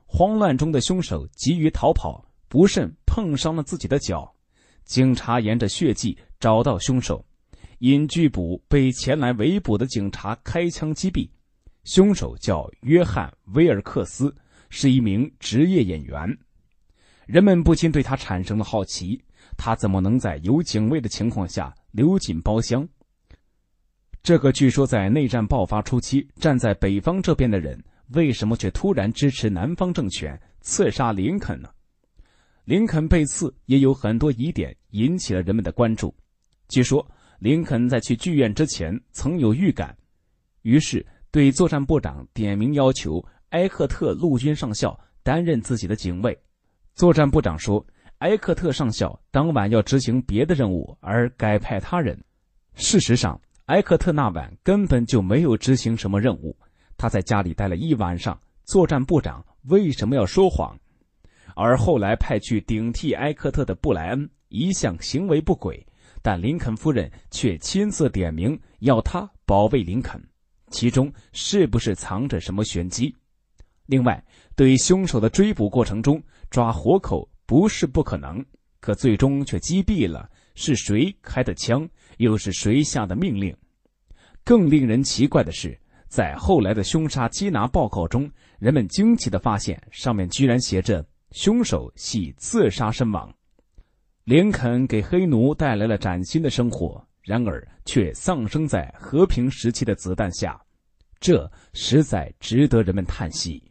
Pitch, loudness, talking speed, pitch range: 120 Hz, -22 LUFS, 230 characters per minute, 100-145 Hz